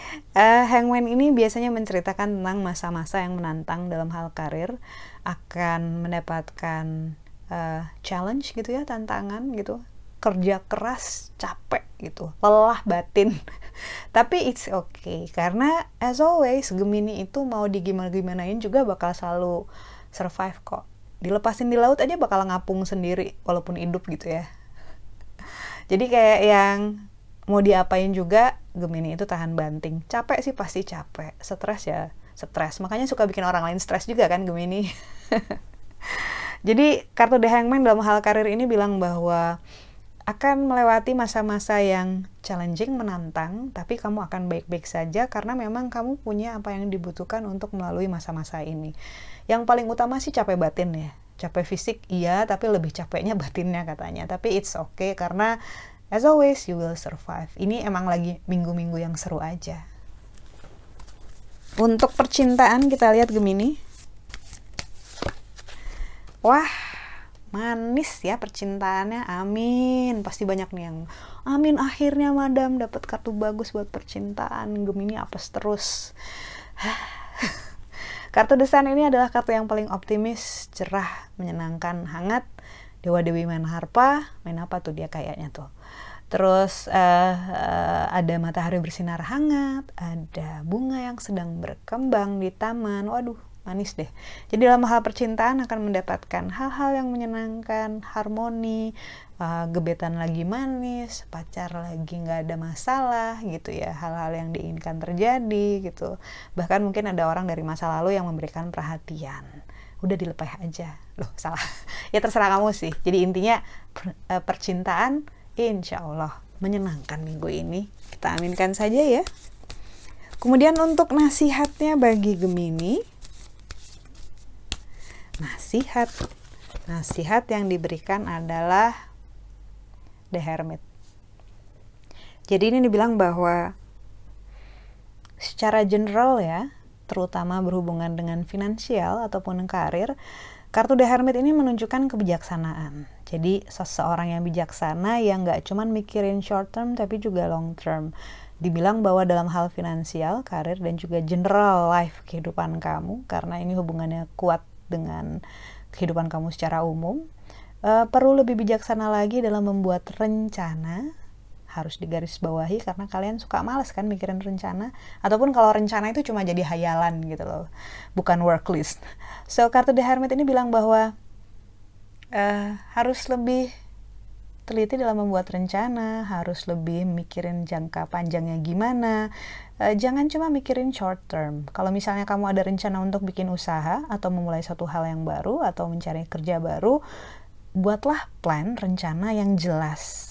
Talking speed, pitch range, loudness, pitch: 125 wpm, 165-225 Hz, -24 LUFS, 185 Hz